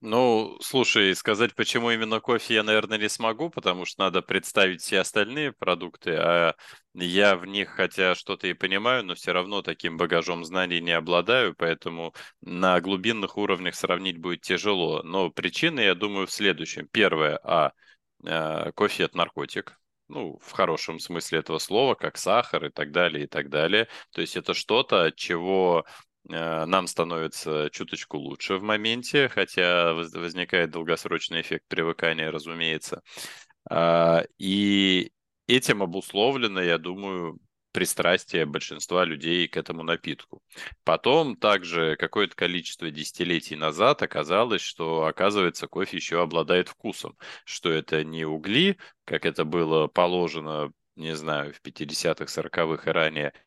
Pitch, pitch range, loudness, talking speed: 90 Hz, 80-100 Hz, -25 LUFS, 140 wpm